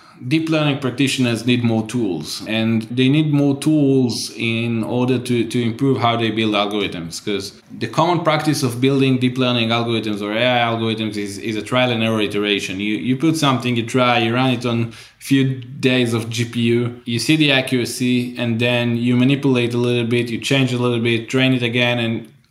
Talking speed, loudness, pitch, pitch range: 195 wpm, -18 LUFS, 120 Hz, 115-130 Hz